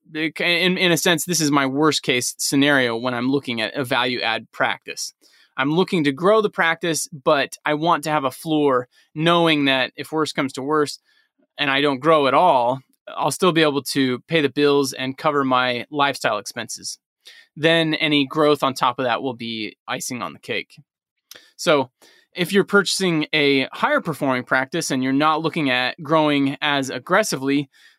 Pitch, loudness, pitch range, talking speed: 150 Hz, -20 LUFS, 135-165 Hz, 185 wpm